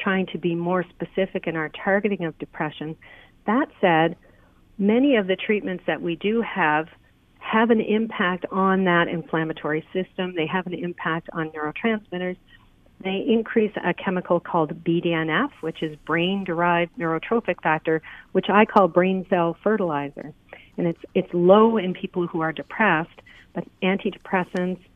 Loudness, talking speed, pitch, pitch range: -23 LUFS, 145 wpm, 180 Hz, 165-195 Hz